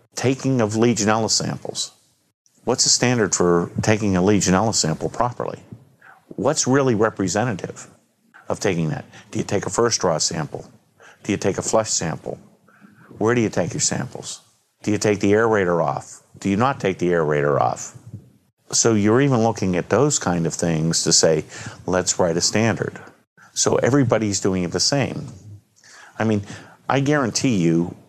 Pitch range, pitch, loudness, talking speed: 90-120 Hz, 105 Hz, -20 LUFS, 165 wpm